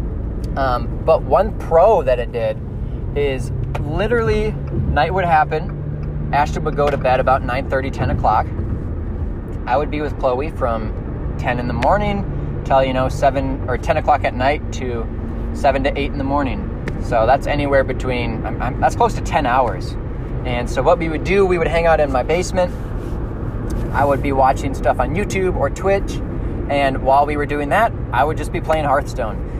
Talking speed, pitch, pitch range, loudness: 185 wpm, 125 Hz, 110-140 Hz, -19 LUFS